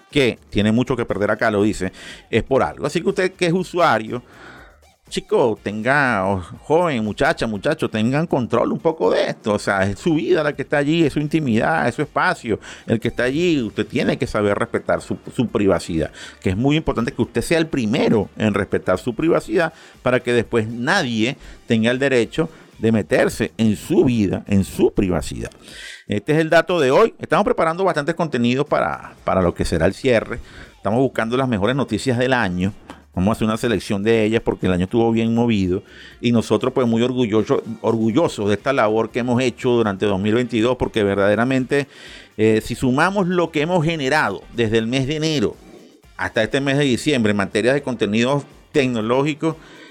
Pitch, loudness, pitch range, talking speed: 120 Hz, -19 LUFS, 110-140 Hz, 190 wpm